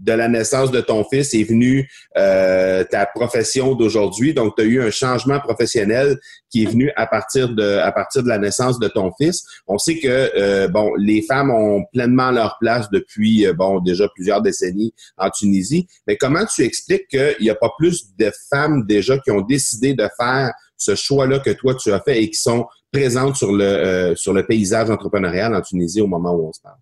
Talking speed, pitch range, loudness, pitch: 215 wpm, 105-135 Hz, -17 LUFS, 115 Hz